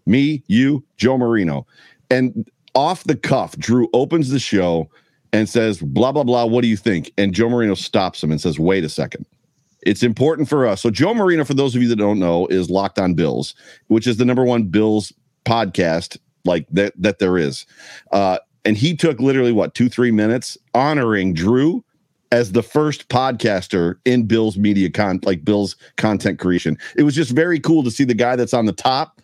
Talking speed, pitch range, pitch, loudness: 200 wpm, 100-135 Hz, 115 Hz, -18 LUFS